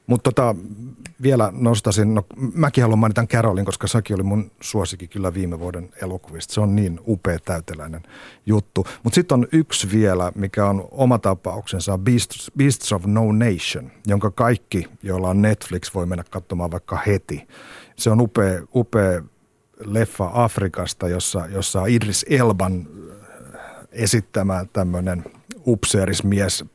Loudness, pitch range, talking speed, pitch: -20 LUFS, 95-115 Hz, 135 wpm, 100 Hz